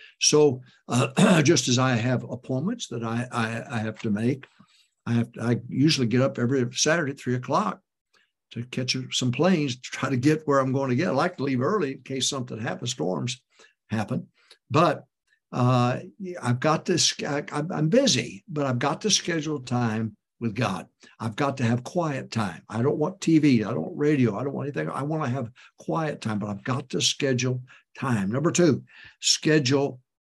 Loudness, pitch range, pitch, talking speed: -25 LUFS, 120-150 Hz, 130 Hz, 195 wpm